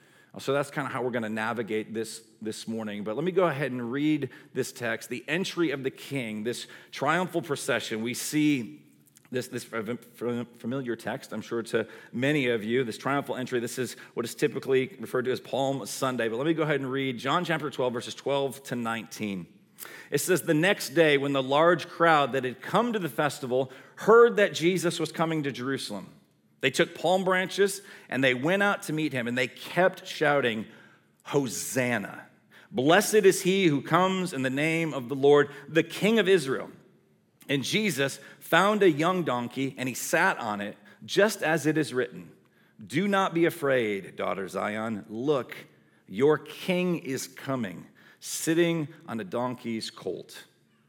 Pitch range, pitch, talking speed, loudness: 120-165 Hz, 140 Hz, 180 wpm, -27 LUFS